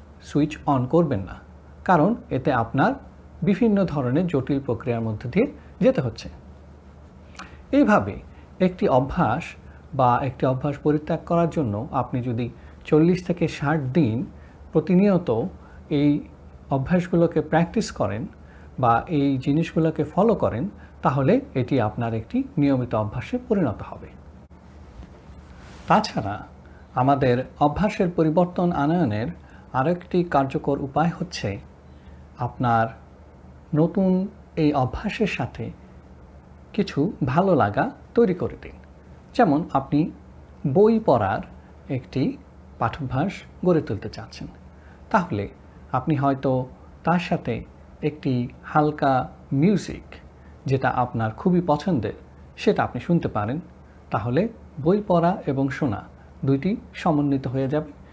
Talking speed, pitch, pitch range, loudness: 105 wpm, 140 Hz, 100-165 Hz, -23 LUFS